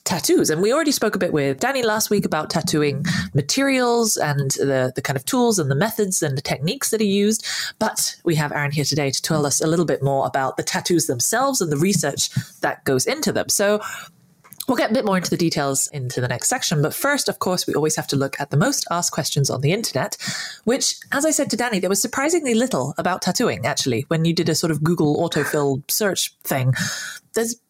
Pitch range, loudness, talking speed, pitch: 145-220 Hz, -20 LUFS, 230 wpm, 170 Hz